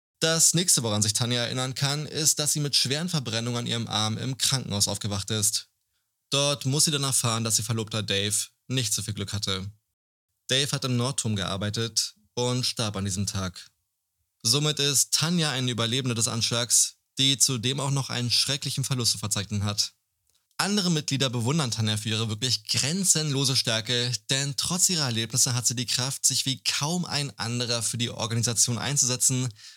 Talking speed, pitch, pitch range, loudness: 175 wpm, 120 Hz, 110-135 Hz, -24 LUFS